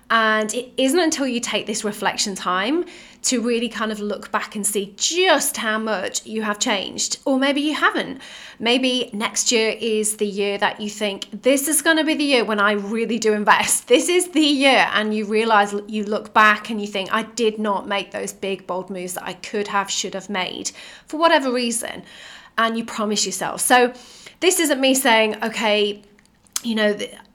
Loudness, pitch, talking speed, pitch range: -20 LUFS, 220 Hz, 200 wpm, 205-250 Hz